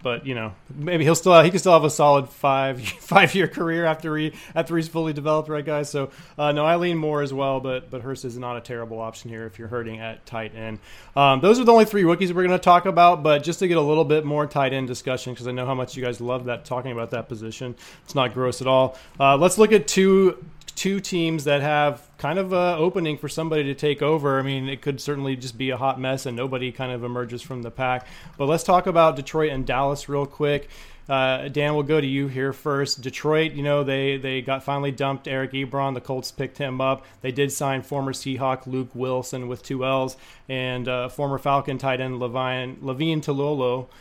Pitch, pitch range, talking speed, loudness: 140 Hz, 130-155 Hz, 240 wpm, -22 LUFS